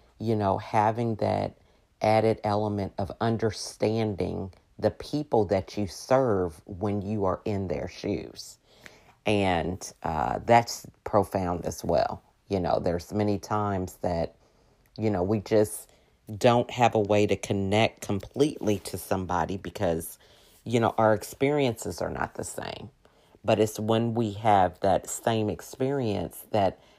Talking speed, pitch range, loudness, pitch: 140 wpm, 95-110 Hz, -27 LUFS, 105 Hz